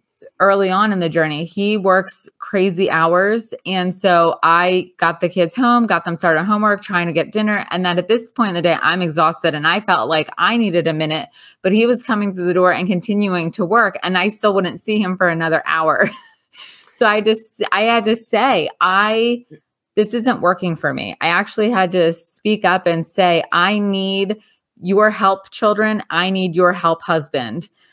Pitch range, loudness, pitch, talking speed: 170-210 Hz, -16 LUFS, 190 Hz, 200 wpm